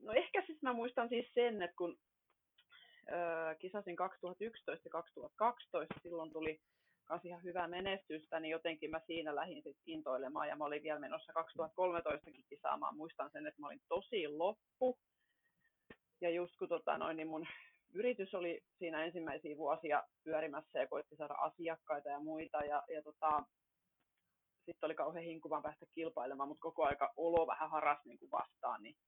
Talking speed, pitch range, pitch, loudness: 155 wpm, 155-195 Hz, 165 Hz, -42 LUFS